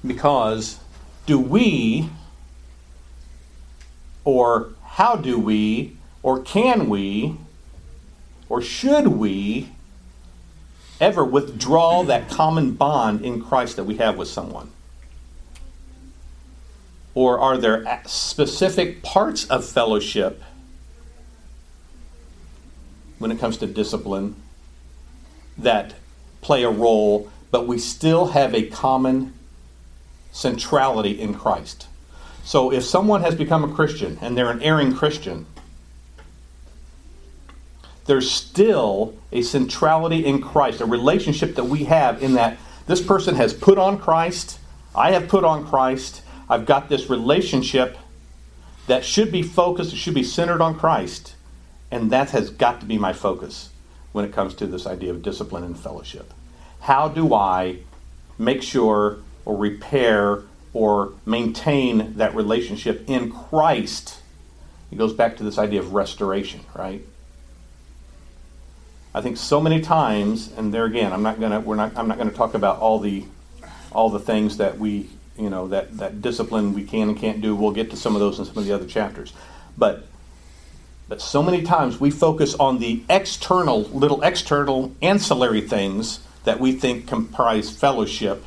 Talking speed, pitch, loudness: 140 wpm, 105 Hz, -20 LUFS